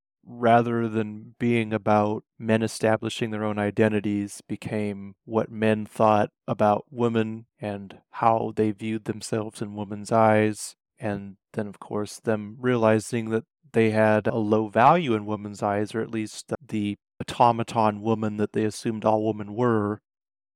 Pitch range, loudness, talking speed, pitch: 105-115 Hz, -25 LUFS, 145 wpm, 110 Hz